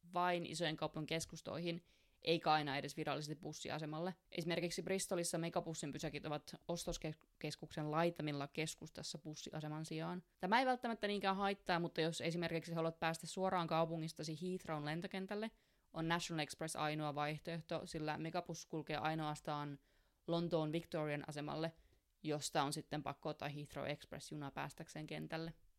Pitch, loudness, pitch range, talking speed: 160 Hz, -43 LUFS, 150-175 Hz, 125 wpm